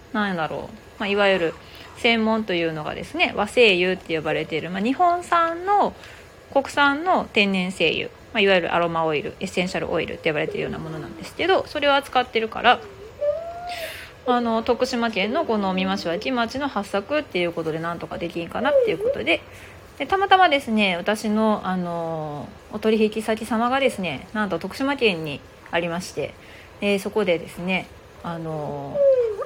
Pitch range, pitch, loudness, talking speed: 175-275 Hz, 215 Hz, -22 LUFS, 355 characters per minute